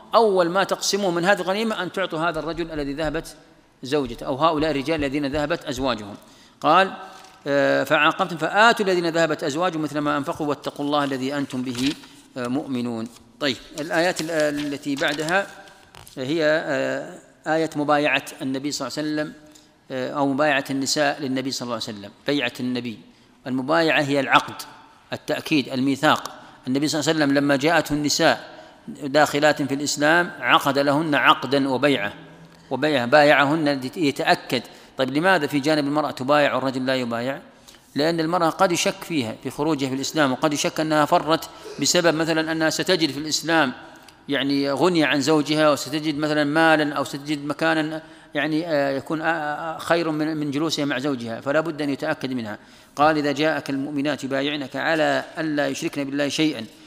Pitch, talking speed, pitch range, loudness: 150 Hz, 145 wpm, 140-160 Hz, -22 LUFS